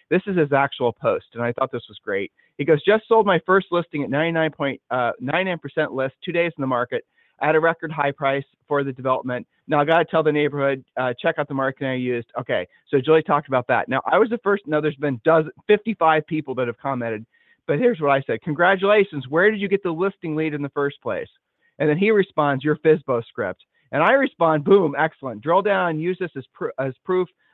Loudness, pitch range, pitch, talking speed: -21 LUFS, 135-180 Hz, 155 Hz, 230 wpm